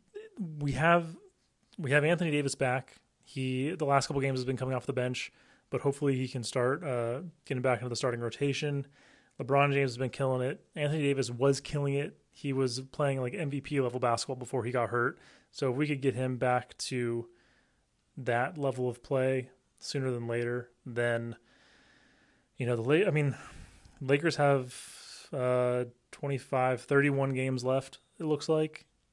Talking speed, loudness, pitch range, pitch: 175 wpm, -31 LUFS, 125-140 Hz, 130 Hz